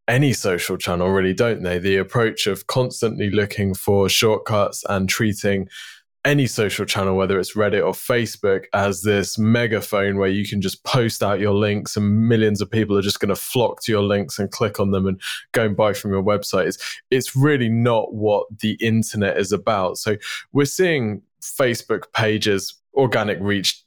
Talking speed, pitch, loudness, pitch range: 185 wpm, 105 Hz, -20 LUFS, 100-110 Hz